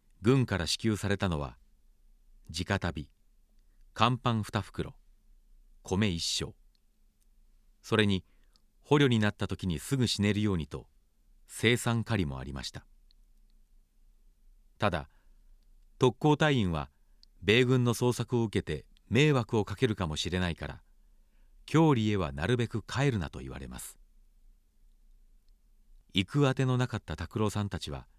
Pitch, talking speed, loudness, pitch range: 100 Hz, 230 characters per minute, -30 LUFS, 75-115 Hz